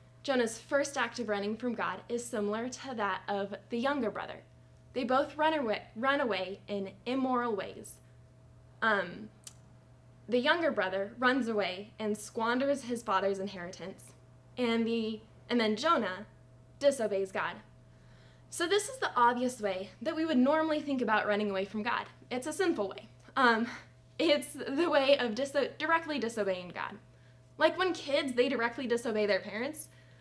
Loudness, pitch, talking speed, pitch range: -32 LUFS, 235 Hz, 155 wpm, 200-275 Hz